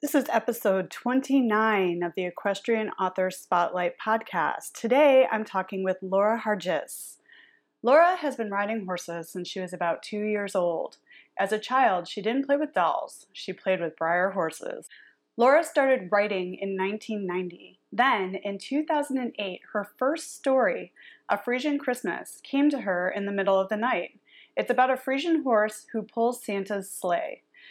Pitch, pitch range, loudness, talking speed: 215 Hz, 190-260 Hz, -26 LUFS, 160 wpm